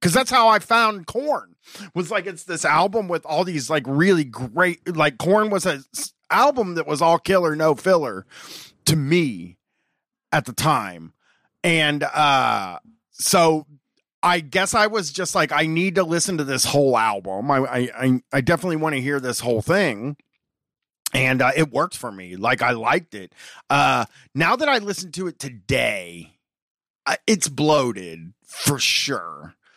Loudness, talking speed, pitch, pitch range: -20 LUFS, 165 wpm, 160 Hz, 135-185 Hz